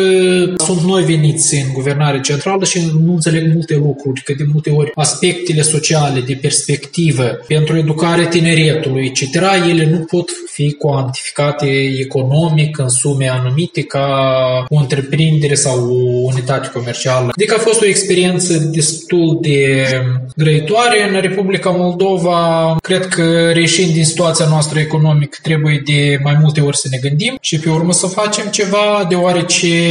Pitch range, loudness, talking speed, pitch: 145-175 Hz, -13 LUFS, 145 wpm, 155 Hz